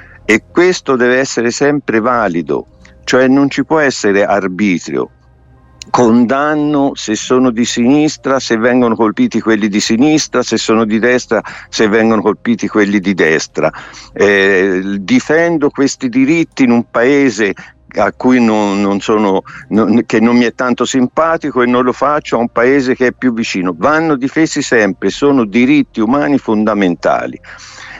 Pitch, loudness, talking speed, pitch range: 120 Hz, -12 LUFS, 150 wpm, 105-140 Hz